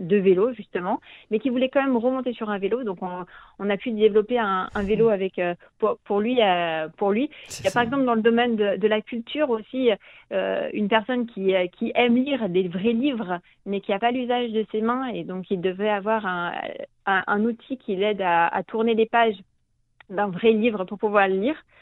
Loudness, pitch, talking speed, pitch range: -24 LUFS, 215 Hz, 225 wpm, 195-235 Hz